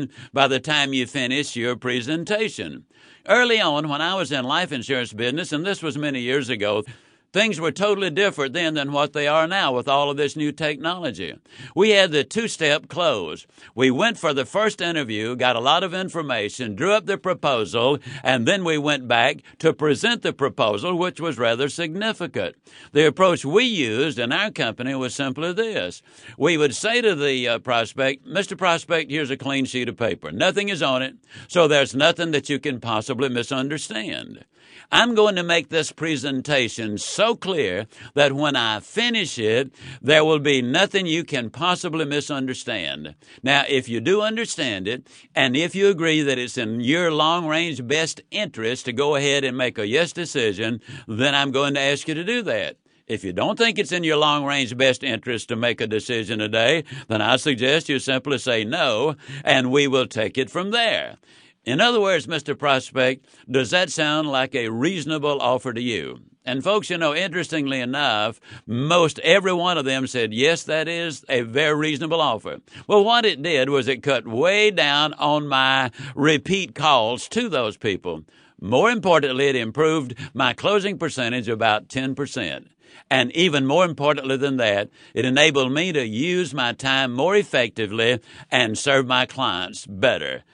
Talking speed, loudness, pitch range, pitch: 180 wpm, -21 LUFS, 130-170 Hz, 145 Hz